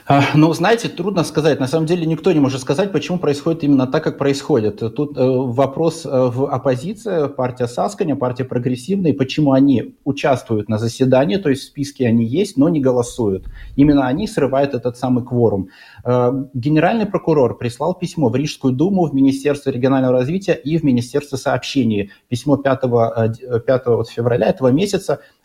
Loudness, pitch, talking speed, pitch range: -17 LUFS, 135 Hz, 155 wpm, 125-155 Hz